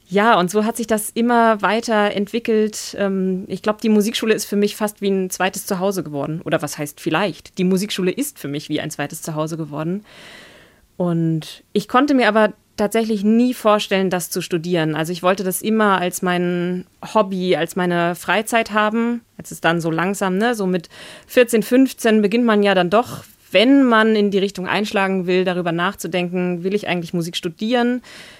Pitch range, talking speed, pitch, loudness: 180-220 Hz, 185 wpm, 195 Hz, -19 LUFS